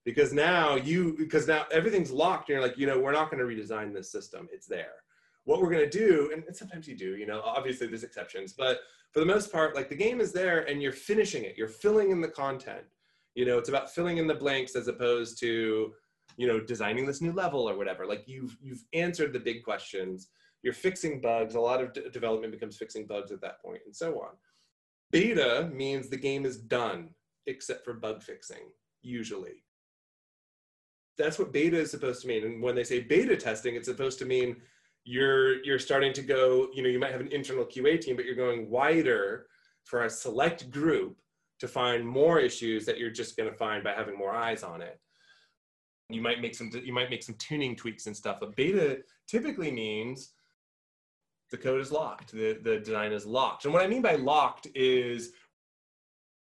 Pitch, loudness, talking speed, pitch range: 135 Hz, -30 LUFS, 205 wpm, 120-180 Hz